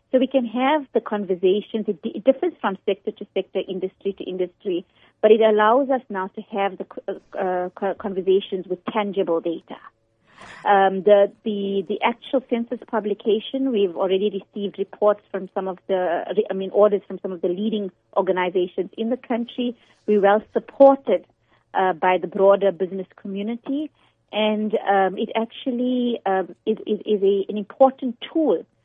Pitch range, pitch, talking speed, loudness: 190-230 Hz, 205 Hz, 160 wpm, -22 LUFS